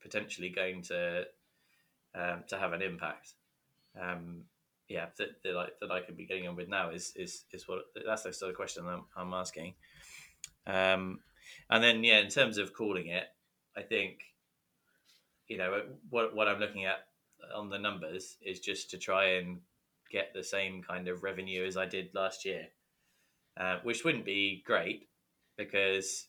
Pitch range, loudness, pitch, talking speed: 90-100 Hz, -34 LUFS, 95 Hz, 175 wpm